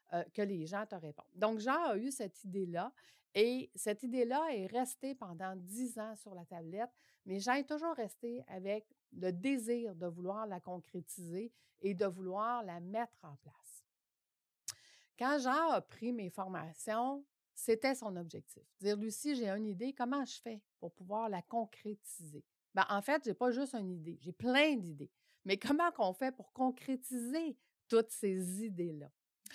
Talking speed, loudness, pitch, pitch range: 165 wpm, -39 LUFS, 215 Hz, 185-250 Hz